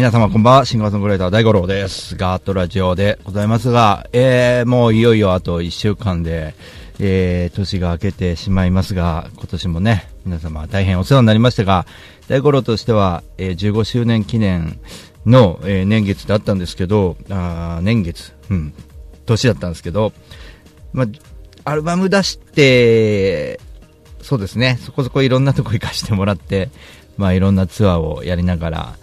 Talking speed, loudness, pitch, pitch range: 345 characters per minute, -16 LUFS, 100 Hz, 90-115 Hz